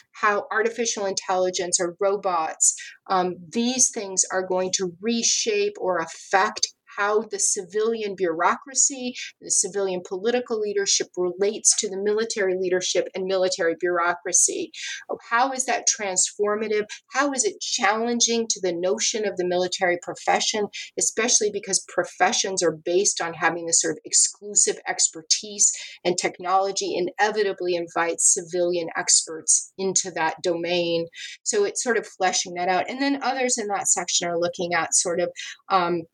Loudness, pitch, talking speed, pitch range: -22 LUFS, 195 Hz, 140 wpm, 180-230 Hz